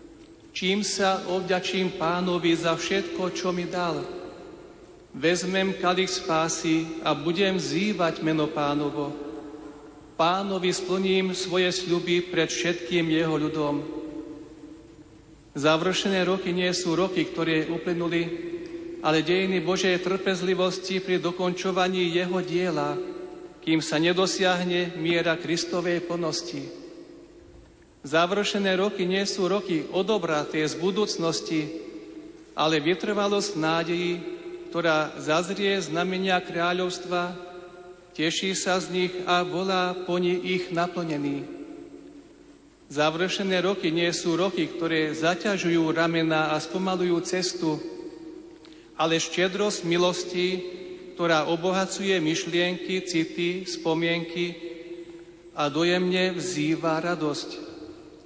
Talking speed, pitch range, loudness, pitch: 95 wpm, 165-190 Hz, -25 LUFS, 180 Hz